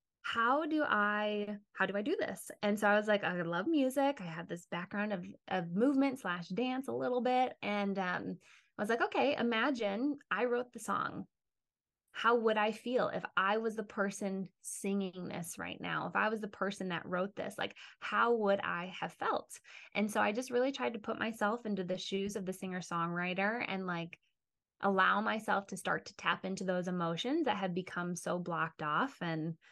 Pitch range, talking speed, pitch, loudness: 185-230 Hz, 200 wpm, 200 Hz, -35 LUFS